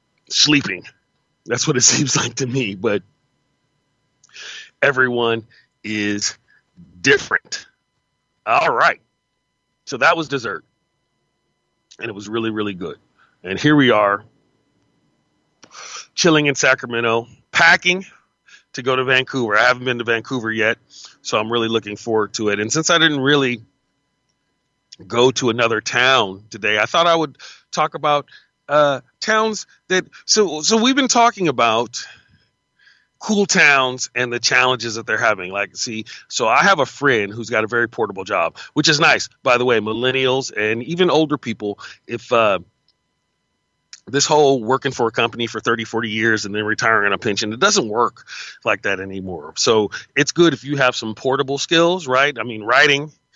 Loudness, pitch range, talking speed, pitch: -17 LUFS, 110-145 Hz, 160 wpm, 125 Hz